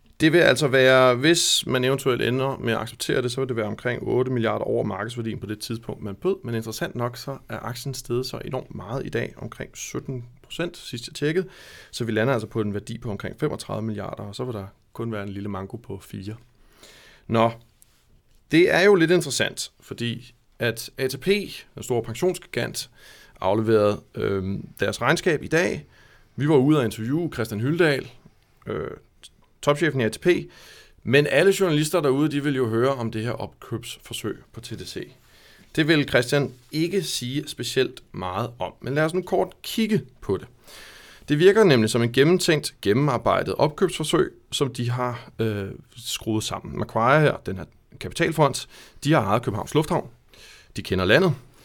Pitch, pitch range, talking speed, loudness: 125 Hz, 110-145 Hz, 175 wpm, -23 LUFS